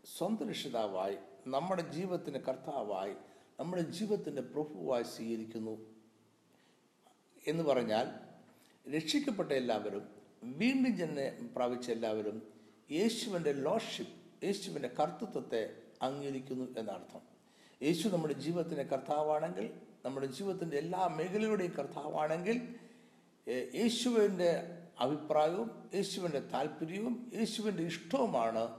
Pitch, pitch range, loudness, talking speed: 160 Hz, 130-210 Hz, -37 LUFS, 80 wpm